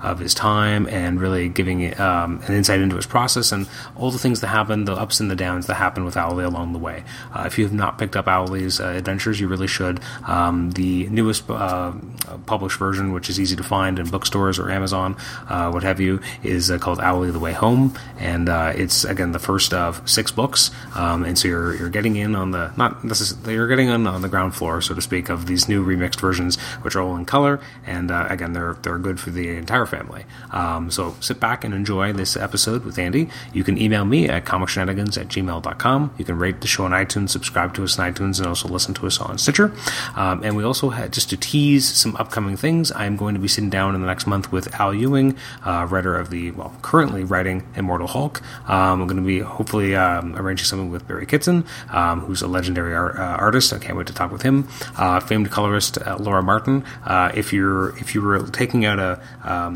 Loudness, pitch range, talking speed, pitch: -20 LUFS, 90-115 Hz, 235 wpm, 95 Hz